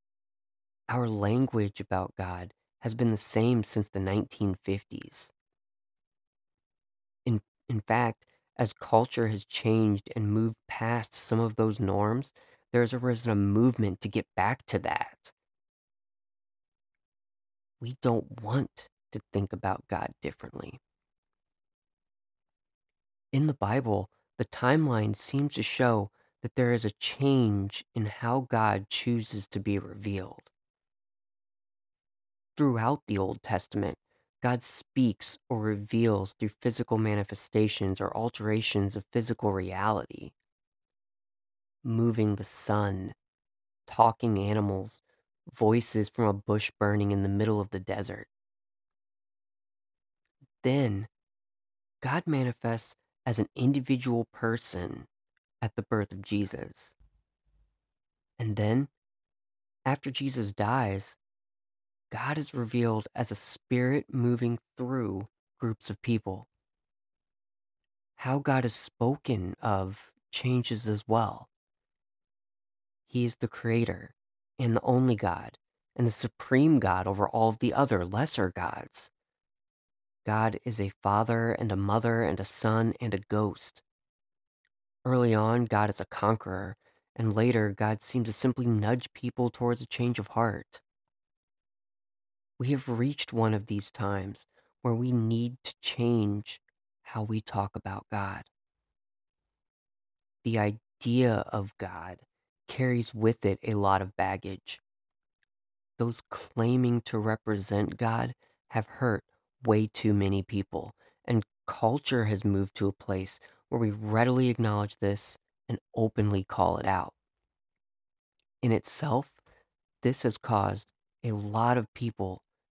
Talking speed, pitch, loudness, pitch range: 120 wpm, 110 Hz, -30 LUFS, 100-120 Hz